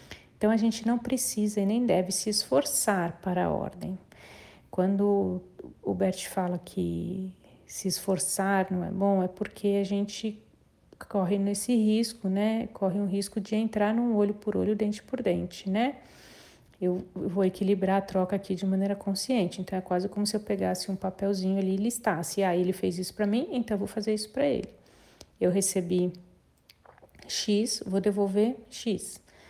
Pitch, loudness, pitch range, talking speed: 200 Hz, -29 LUFS, 185-215 Hz, 170 wpm